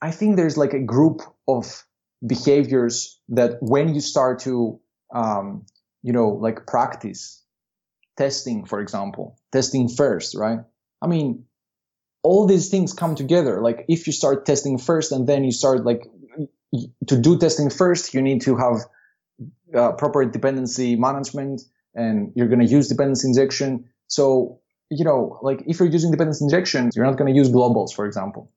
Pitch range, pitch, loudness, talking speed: 125-150 Hz, 135 Hz, -20 LUFS, 165 wpm